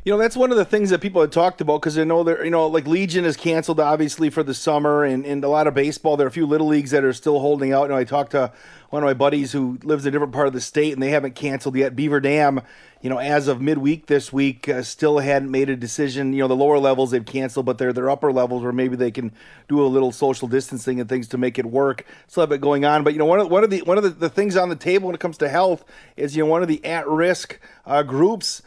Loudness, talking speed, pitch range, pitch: -20 LUFS, 300 wpm, 135-160 Hz, 145 Hz